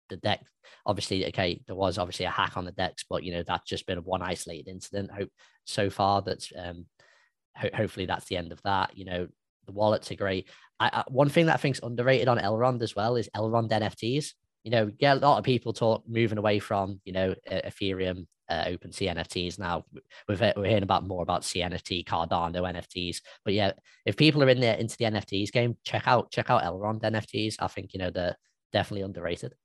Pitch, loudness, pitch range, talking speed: 100 Hz, -28 LUFS, 90-115 Hz, 220 wpm